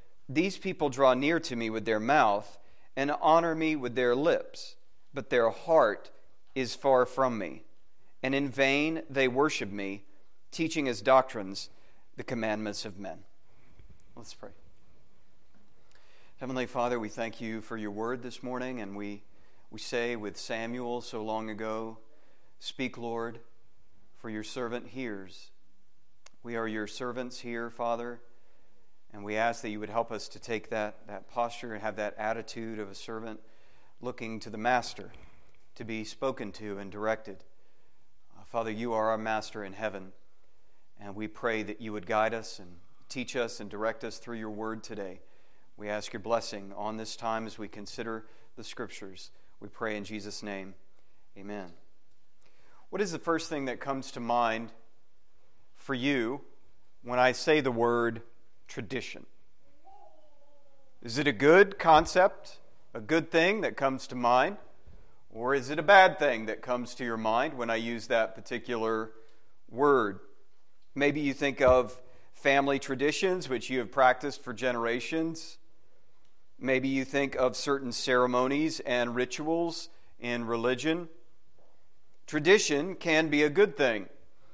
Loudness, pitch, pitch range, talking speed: -30 LUFS, 120 Hz, 110-135 Hz, 155 wpm